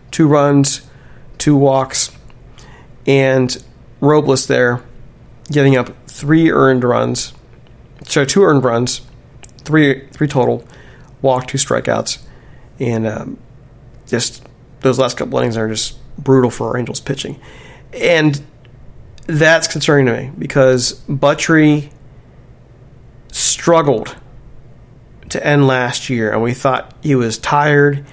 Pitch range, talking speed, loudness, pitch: 125-140 Hz, 115 wpm, -14 LUFS, 130 Hz